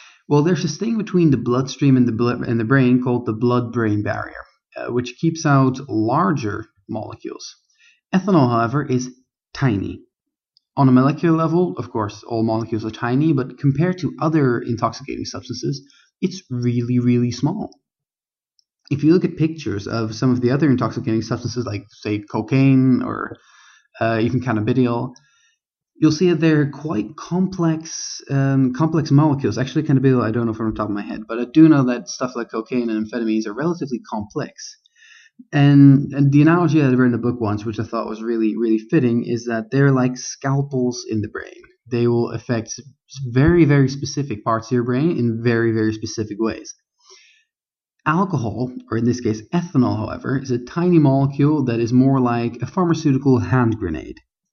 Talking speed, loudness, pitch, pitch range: 180 wpm, -19 LUFS, 125 Hz, 115-150 Hz